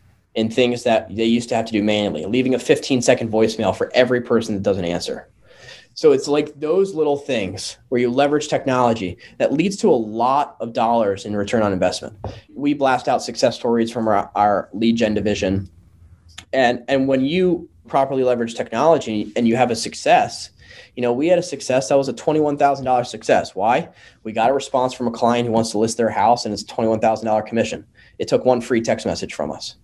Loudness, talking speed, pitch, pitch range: -19 LUFS, 205 wpm, 115 Hz, 110-130 Hz